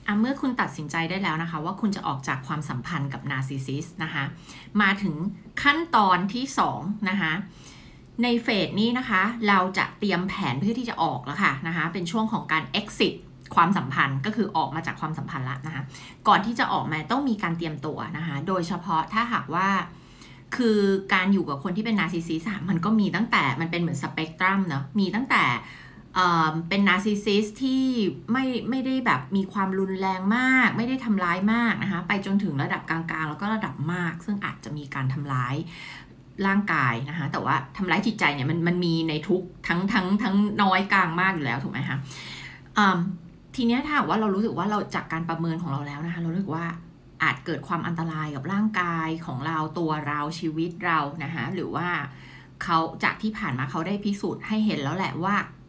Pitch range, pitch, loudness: 155-205 Hz, 175 Hz, -25 LUFS